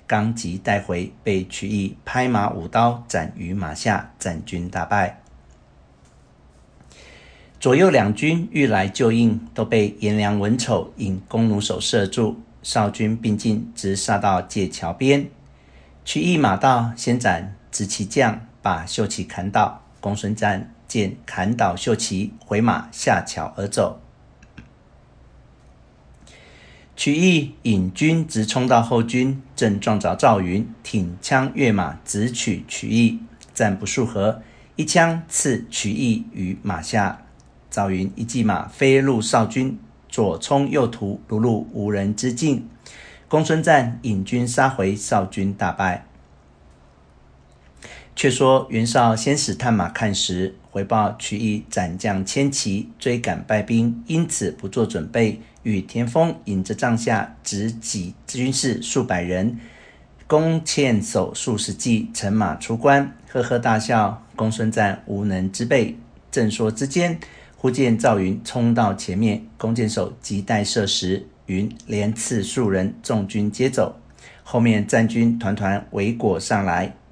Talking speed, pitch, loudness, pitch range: 190 characters per minute, 110 Hz, -21 LUFS, 95-120 Hz